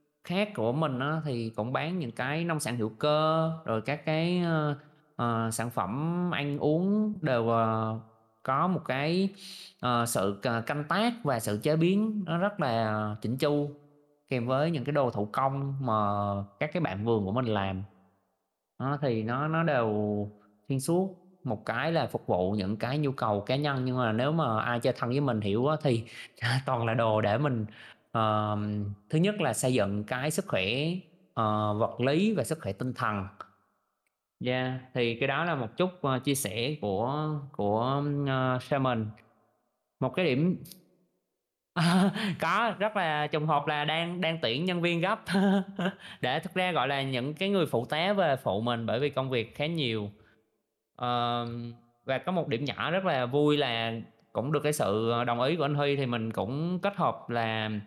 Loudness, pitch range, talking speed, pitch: -29 LUFS, 115-160 Hz, 180 wpm, 130 Hz